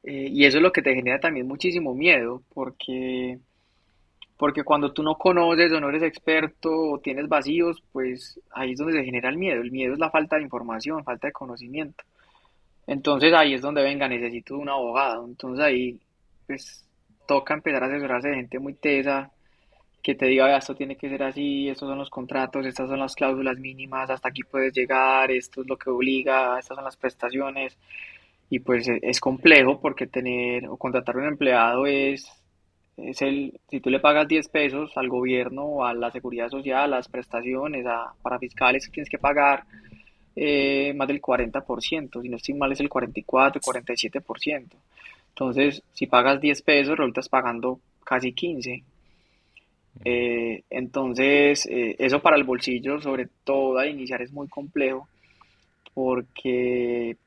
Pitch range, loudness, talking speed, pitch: 125-140 Hz, -23 LUFS, 170 wpm, 130 Hz